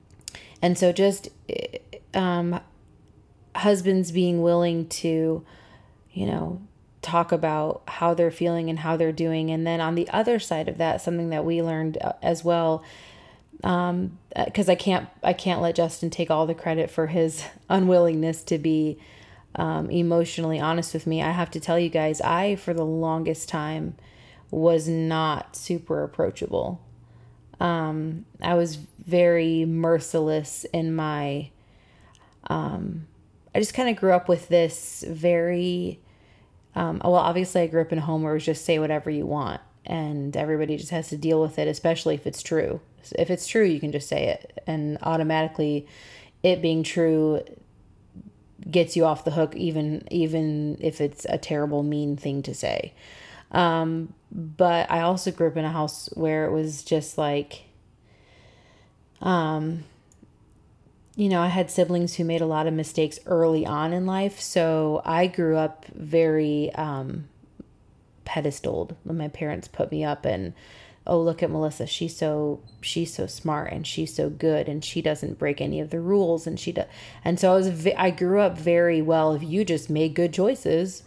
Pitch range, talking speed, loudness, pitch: 150-170 Hz, 170 wpm, -25 LUFS, 160 Hz